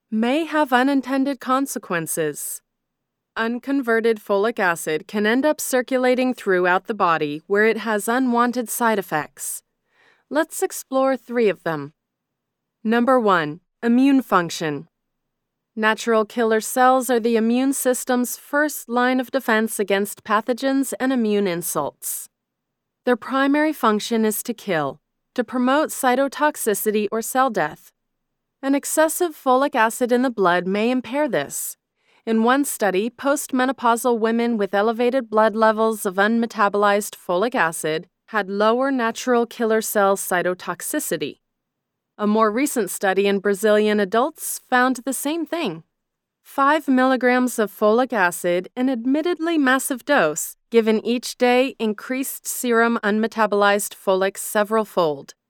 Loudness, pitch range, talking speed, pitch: -20 LUFS, 205-260 Hz, 125 wpm, 230 Hz